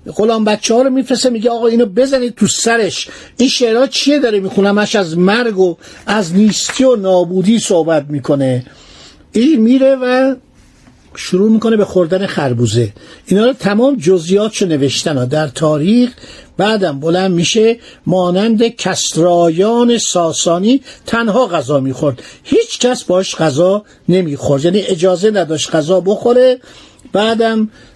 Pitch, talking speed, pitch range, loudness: 205 Hz, 135 wpm, 175-240 Hz, -13 LUFS